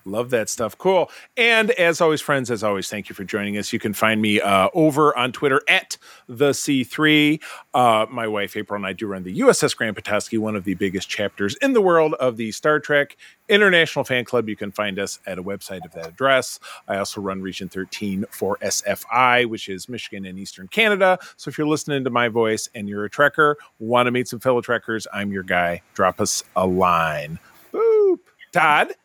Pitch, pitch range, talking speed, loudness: 120 Hz, 100-150 Hz, 210 wpm, -20 LUFS